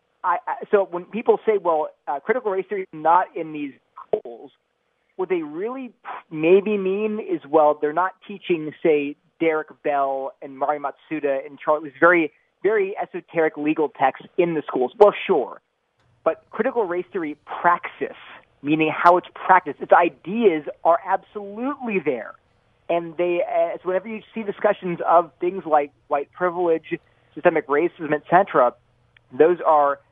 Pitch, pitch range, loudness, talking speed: 170 Hz, 150-205 Hz, -22 LUFS, 150 wpm